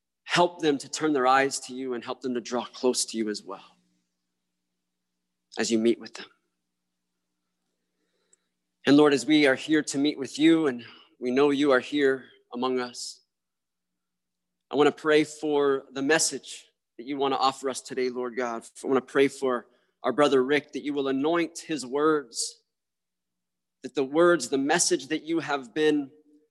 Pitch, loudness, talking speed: 130 Hz, -25 LUFS, 180 wpm